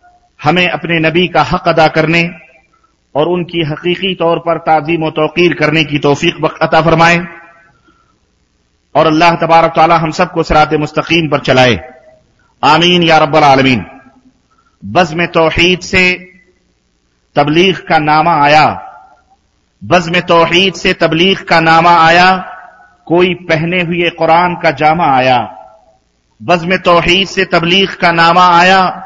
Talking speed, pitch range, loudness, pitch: 120 wpm, 155-180 Hz, -9 LUFS, 165 Hz